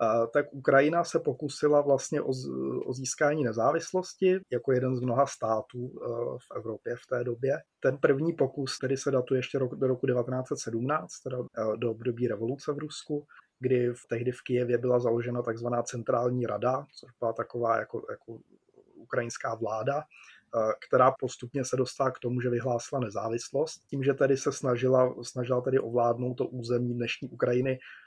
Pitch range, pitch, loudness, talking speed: 120-140 Hz, 125 Hz, -29 LUFS, 155 wpm